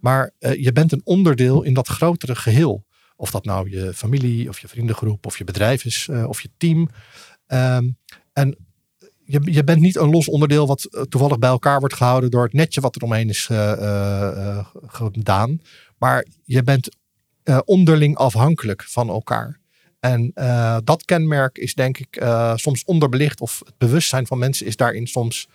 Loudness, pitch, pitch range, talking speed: -19 LUFS, 130 Hz, 115-145 Hz, 185 wpm